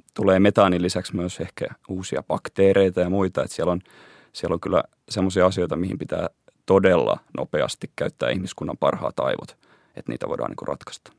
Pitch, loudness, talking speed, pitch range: 95 Hz, -23 LUFS, 165 wpm, 90-95 Hz